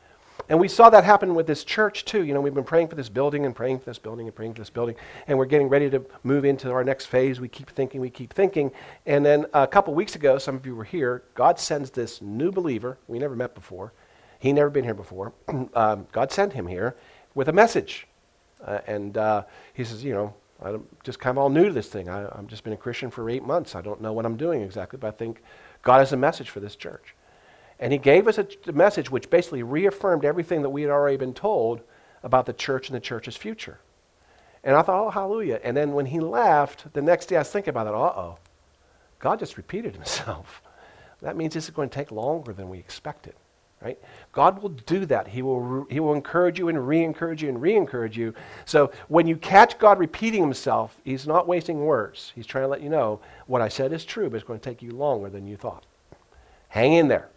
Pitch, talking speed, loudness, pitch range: 135 Hz, 240 wpm, -23 LUFS, 115-155 Hz